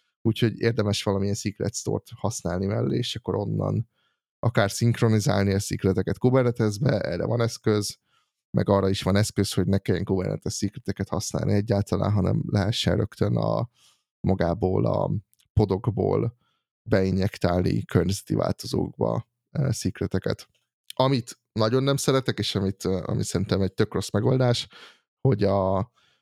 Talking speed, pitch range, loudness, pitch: 125 wpm, 95-115 Hz, -25 LUFS, 100 Hz